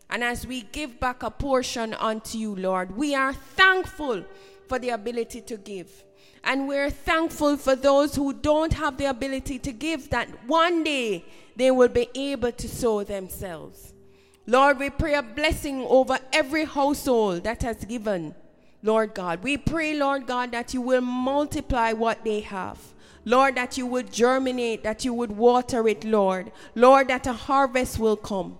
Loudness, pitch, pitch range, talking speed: -24 LUFS, 250 Hz, 220-280 Hz, 170 wpm